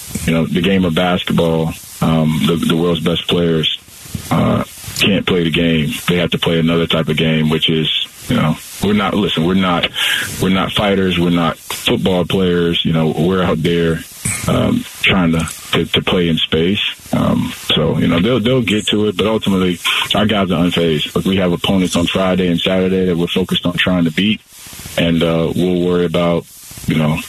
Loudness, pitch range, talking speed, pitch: -15 LUFS, 80-95 Hz, 200 wpm, 85 Hz